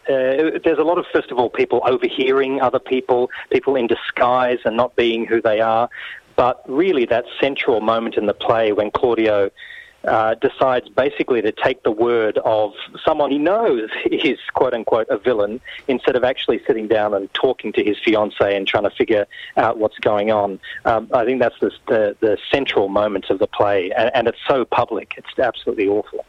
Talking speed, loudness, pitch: 195 wpm, -18 LUFS, 130 Hz